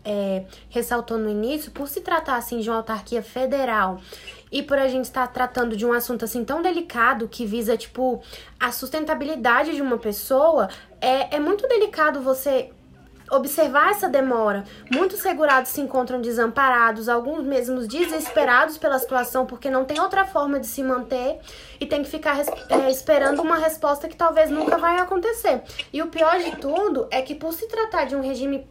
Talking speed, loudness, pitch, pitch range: 175 wpm, -22 LUFS, 270 Hz, 245-315 Hz